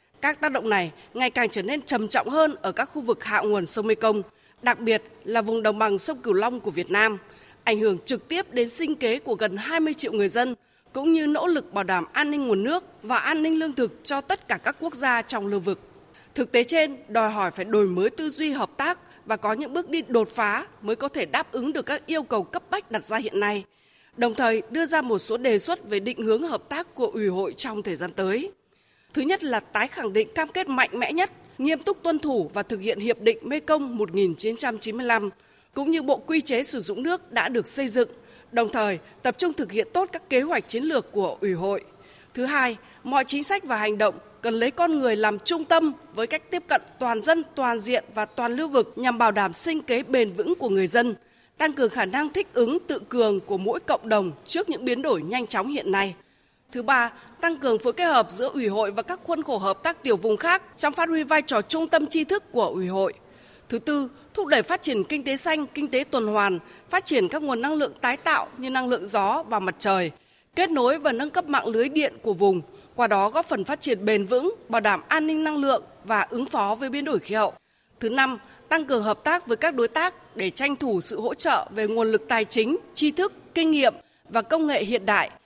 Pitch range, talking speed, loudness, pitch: 220-315 Hz, 245 wpm, -24 LUFS, 255 Hz